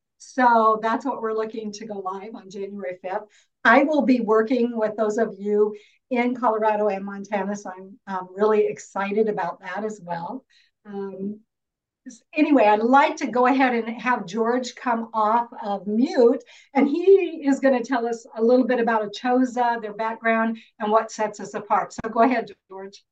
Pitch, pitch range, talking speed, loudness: 225 Hz, 210-250 Hz, 180 wpm, -22 LUFS